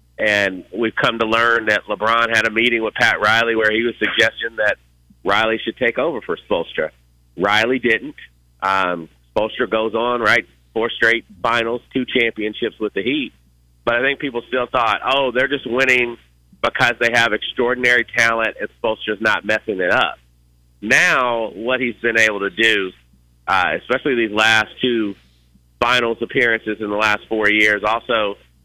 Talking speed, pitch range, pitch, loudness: 170 wpm, 90-115 Hz, 110 Hz, -17 LUFS